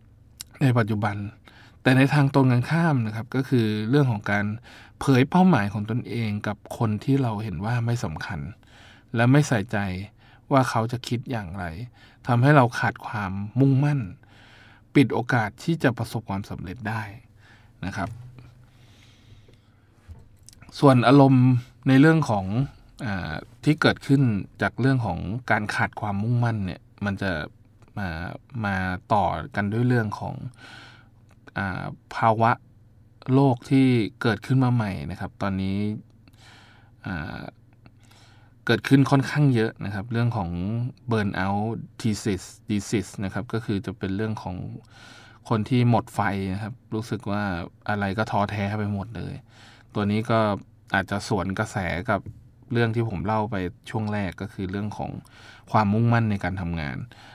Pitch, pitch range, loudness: 110 Hz, 100-120 Hz, -24 LUFS